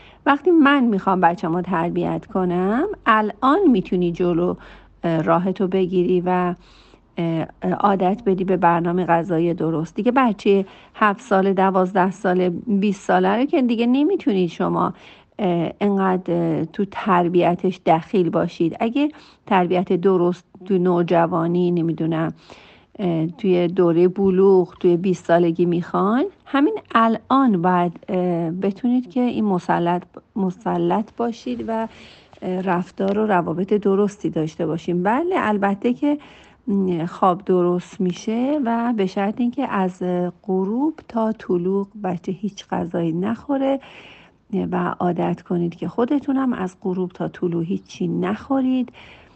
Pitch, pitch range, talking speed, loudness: 185 Hz, 175-220 Hz, 115 wpm, -20 LUFS